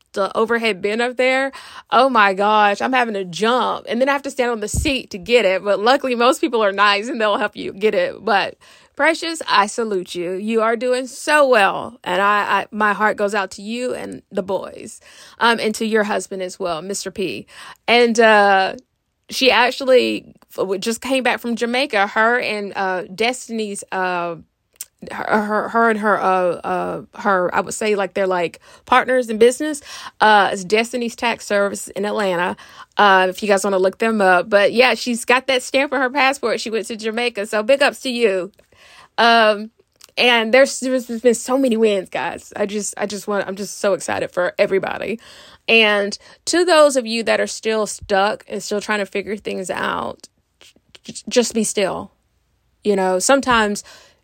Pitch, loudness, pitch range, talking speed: 220 Hz, -18 LUFS, 200-250 Hz, 195 wpm